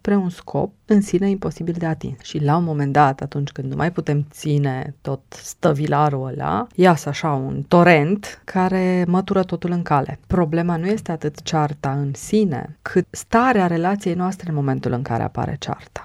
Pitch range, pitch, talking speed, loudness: 145-185 Hz, 165 Hz, 180 wpm, -20 LUFS